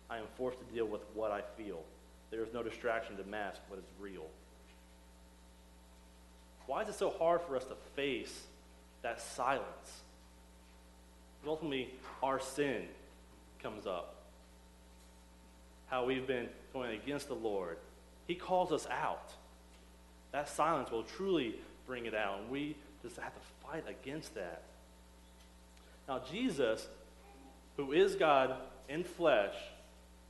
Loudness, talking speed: -38 LUFS, 135 wpm